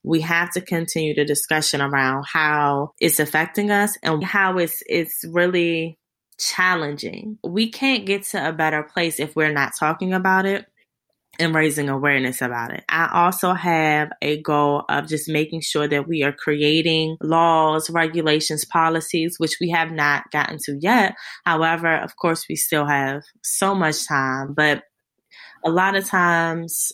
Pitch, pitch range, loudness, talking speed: 160 Hz, 150-175 Hz, -20 LUFS, 160 wpm